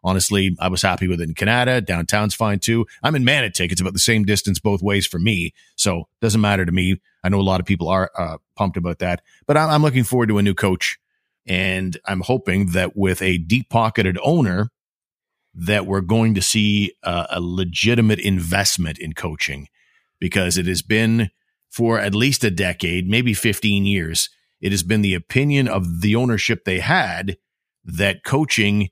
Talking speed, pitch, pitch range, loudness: 190 wpm, 100 Hz, 90-110 Hz, -19 LUFS